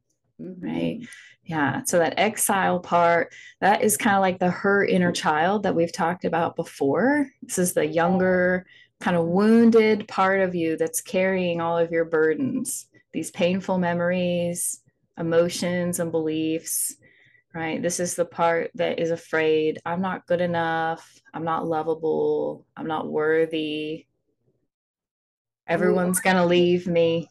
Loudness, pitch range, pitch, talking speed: -23 LUFS, 165-185 Hz, 170 Hz, 145 wpm